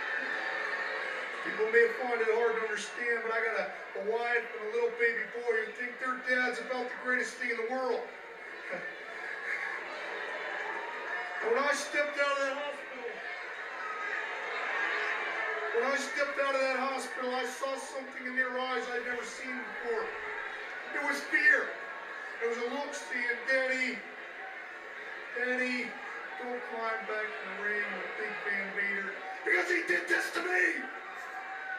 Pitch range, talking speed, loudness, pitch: 235-300 Hz, 150 wpm, -32 LUFS, 255 Hz